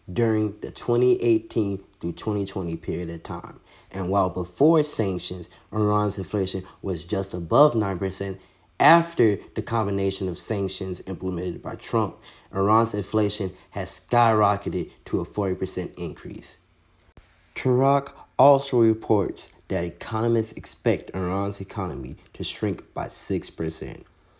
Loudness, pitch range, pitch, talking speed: -24 LUFS, 90-110 Hz, 95 Hz, 115 wpm